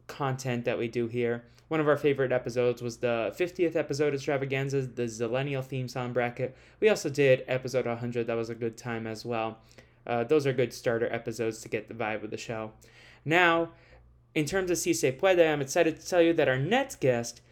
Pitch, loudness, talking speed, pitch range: 125 Hz, -29 LUFS, 210 wpm, 120-150 Hz